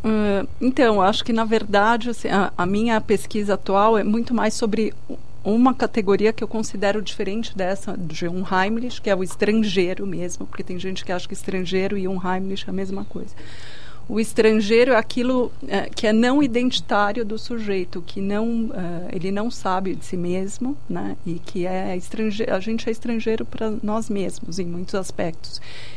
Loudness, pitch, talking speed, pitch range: -22 LUFS, 205 Hz, 185 wpm, 190-225 Hz